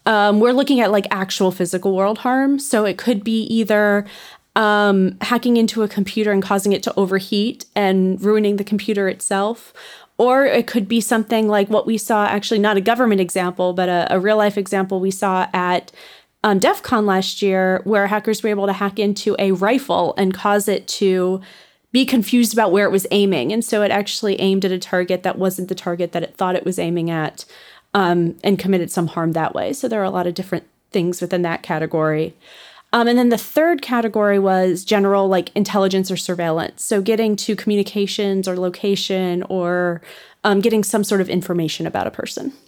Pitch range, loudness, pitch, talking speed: 185-215 Hz, -18 LUFS, 200 Hz, 200 wpm